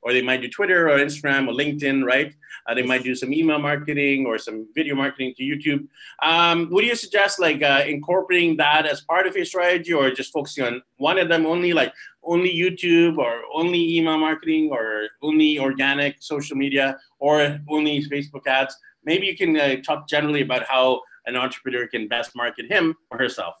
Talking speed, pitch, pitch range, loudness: 195 wpm, 145 Hz, 130-165 Hz, -21 LUFS